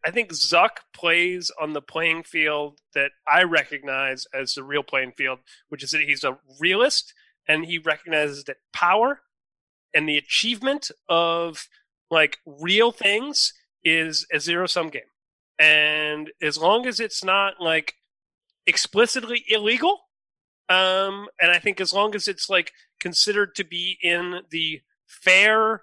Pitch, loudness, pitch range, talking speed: 170 Hz, -21 LUFS, 150-205 Hz, 145 wpm